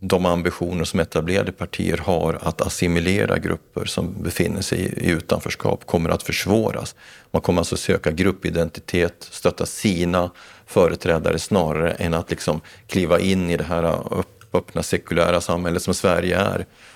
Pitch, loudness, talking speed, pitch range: 90 Hz, -22 LUFS, 145 wpm, 85-95 Hz